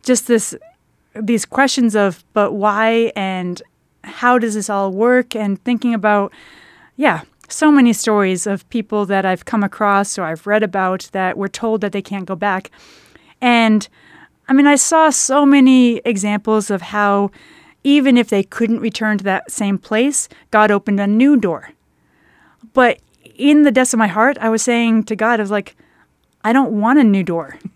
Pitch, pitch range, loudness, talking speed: 220 Hz, 200-245 Hz, -15 LUFS, 180 wpm